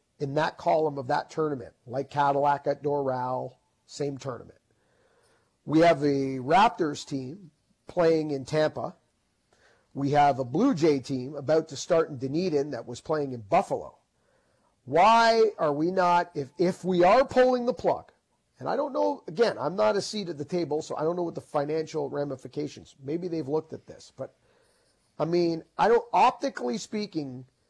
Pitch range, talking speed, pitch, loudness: 140-175 Hz, 170 wpm, 155 Hz, -26 LUFS